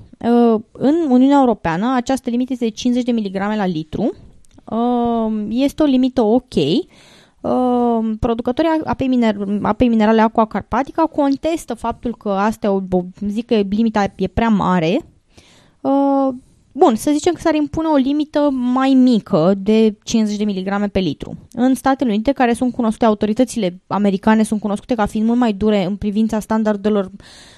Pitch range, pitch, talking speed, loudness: 210-260 Hz, 230 Hz, 155 wpm, -17 LUFS